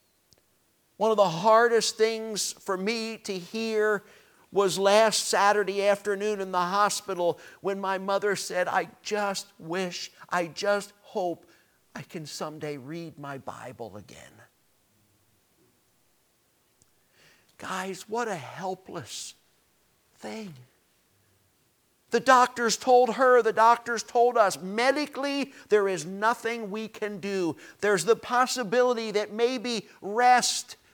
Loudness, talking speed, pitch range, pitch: -26 LUFS, 115 wpm, 185-225 Hz, 205 Hz